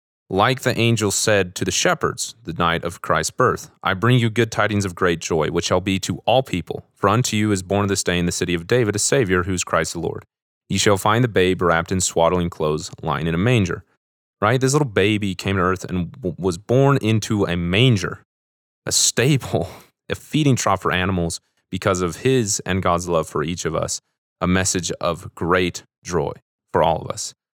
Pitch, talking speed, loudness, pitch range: 95 Hz, 210 wpm, -20 LUFS, 90-110 Hz